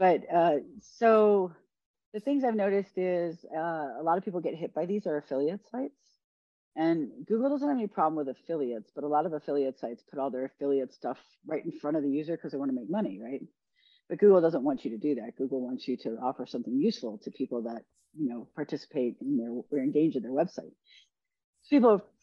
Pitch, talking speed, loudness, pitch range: 160 Hz, 220 wpm, -30 LUFS, 140-210 Hz